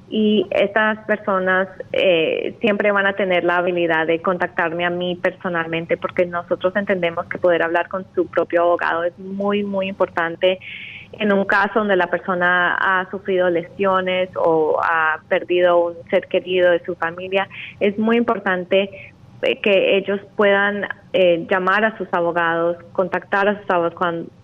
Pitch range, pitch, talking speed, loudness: 175-200 Hz, 185 Hz, 150 wpm, -19 LUFS